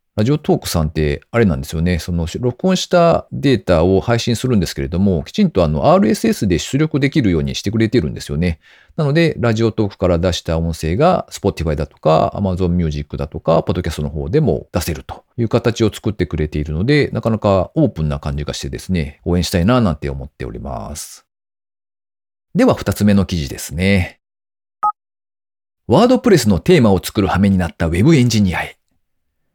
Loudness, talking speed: -16 LUFS, 430 characters per minute